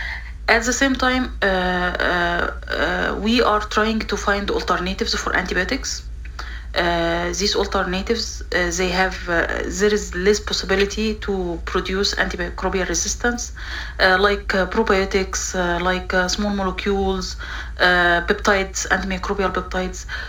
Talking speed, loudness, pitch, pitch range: 125 wpm, -20 LUFS, 190 Hz, 180-210 Hz